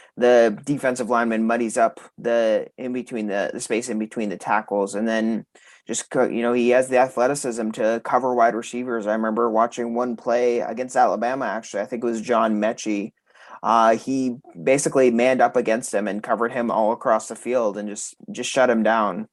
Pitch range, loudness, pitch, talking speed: 110-125 Hz, -22 LUFS, 120 Hz, 190 wpm